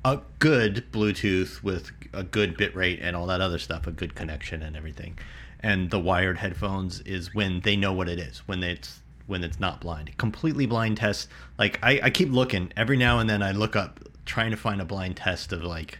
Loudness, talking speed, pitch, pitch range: -26 LUFS, 220 wpm, 95 Hz, 85-105 Hz